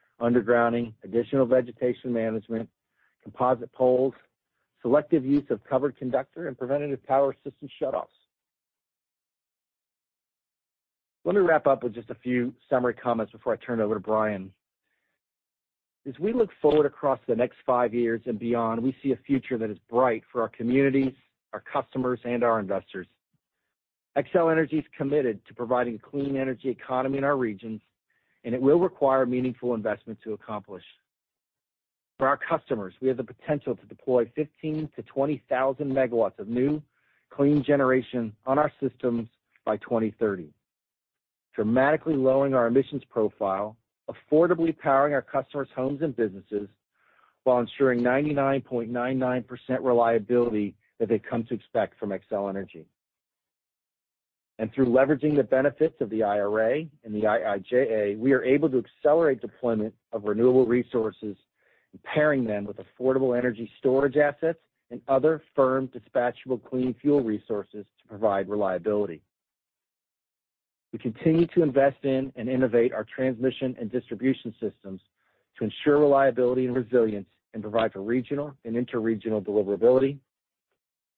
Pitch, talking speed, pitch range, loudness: 125 Hz, 140 wpm, 115-135 Hz, -26 LUFS